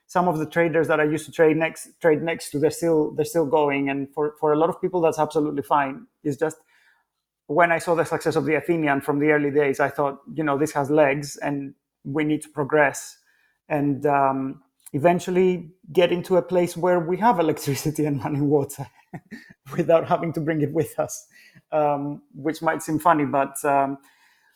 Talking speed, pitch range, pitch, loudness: 200 wpm, 145-165 Hz, 155 Hz, -23 LUFS